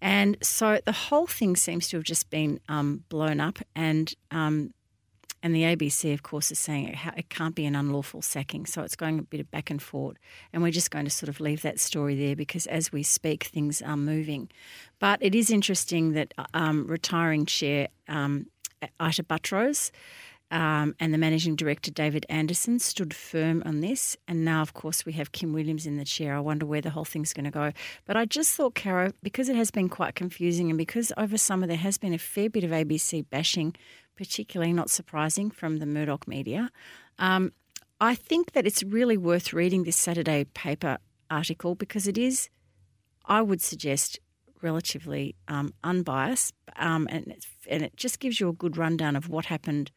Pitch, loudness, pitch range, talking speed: 160 Hz, -27 LUFS, 150-190 Hz, 200 wpm